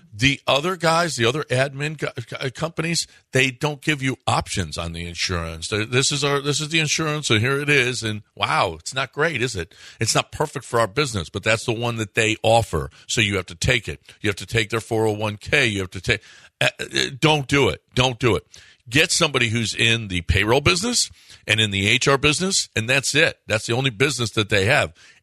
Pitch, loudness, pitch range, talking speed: 120 Hz, -20 LUFS, 105-145 Hz, 215 wpm